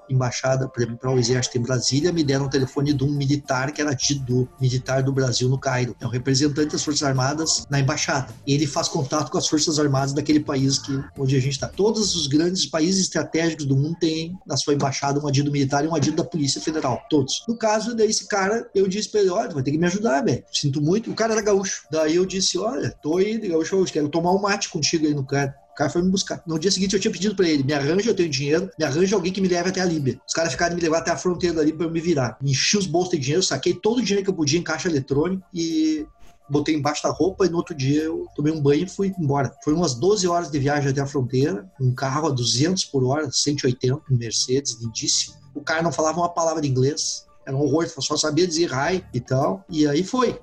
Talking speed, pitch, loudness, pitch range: 255 wpm, 155 Hz, -22 LUFS, 140-175 Hz